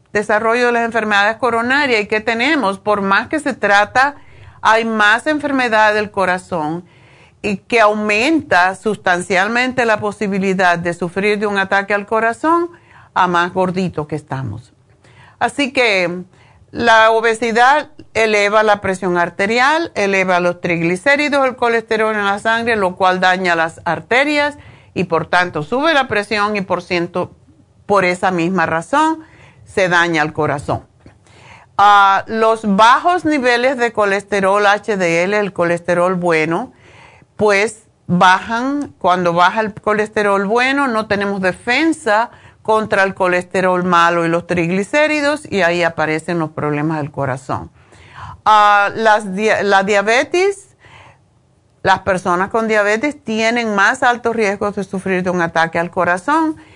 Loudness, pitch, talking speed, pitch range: -15 LUFS, 200 Hz, 135 wpm, 180-225 Hz